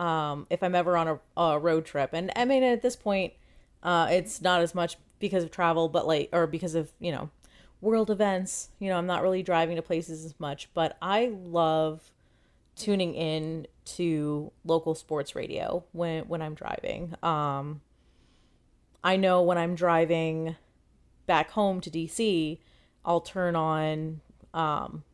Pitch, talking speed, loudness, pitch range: 170 Hz, 165 wpm, -28 LUFS, 155-180 Hz